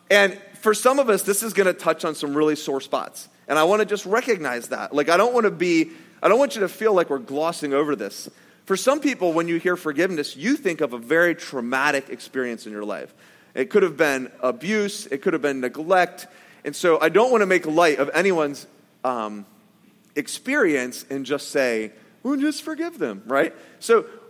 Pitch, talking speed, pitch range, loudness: 175 Hz, 210 wpm, 145-210 Hz, -22 LUFS